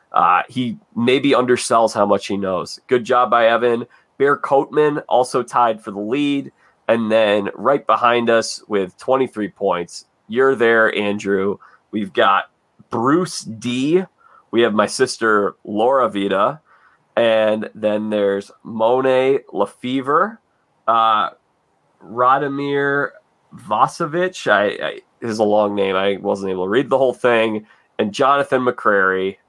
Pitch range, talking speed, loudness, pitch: 105-135 Hz, 130 wpm, -18 LUFS, 120 Hz